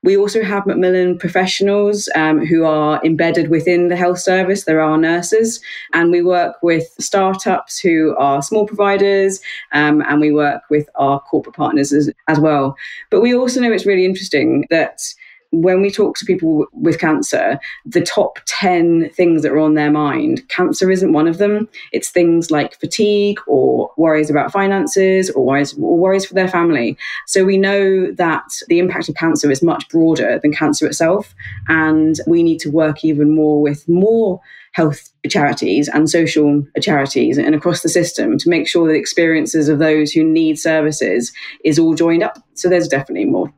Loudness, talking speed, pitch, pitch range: -15 LUFS, 180 wpm, 165 Hz, 155-190 Hz